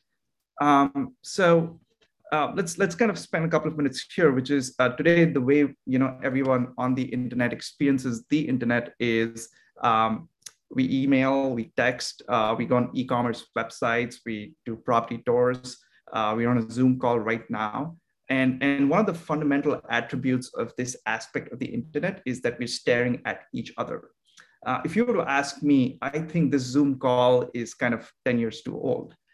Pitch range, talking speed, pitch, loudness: 120-145 Hz, 185 wpm, 130 Hz, -25 LUFS